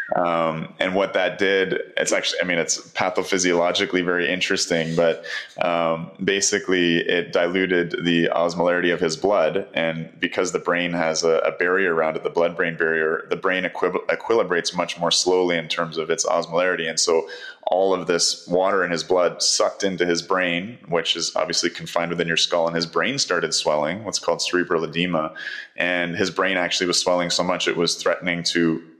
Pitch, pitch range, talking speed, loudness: 85 Hz, 85-90 Hz, 185 wpm, -21 LUFS